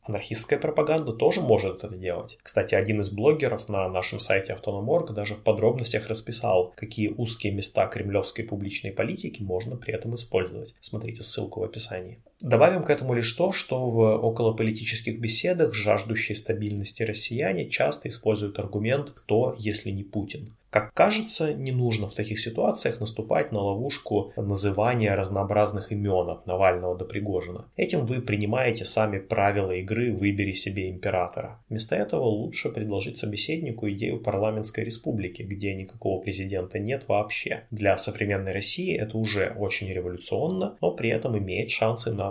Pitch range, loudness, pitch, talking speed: 100-115 Hz, -26 LUFS, 105 Hz, 145 wpm